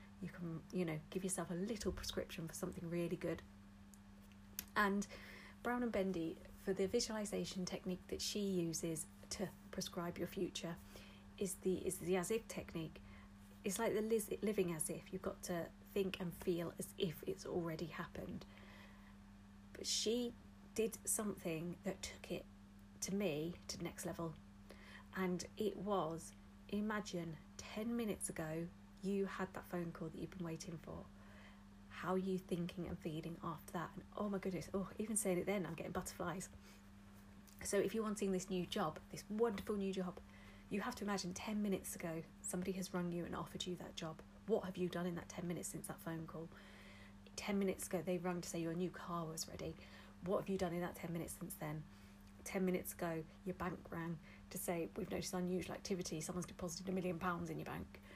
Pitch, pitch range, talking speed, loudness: 175 Hz, 155-190 Hz, 190 wpm, -44 LUFS